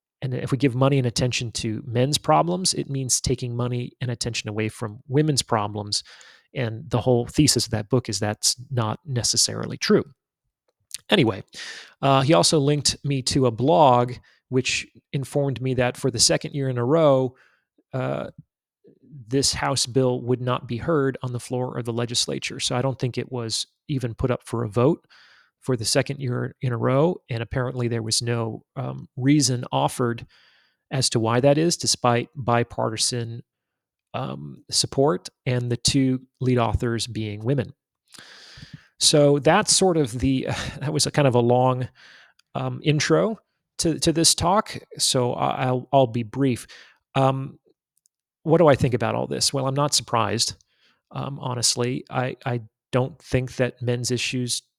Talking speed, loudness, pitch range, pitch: 170 wpm, -22 LUFS, 120-140 Hz, 125 Hz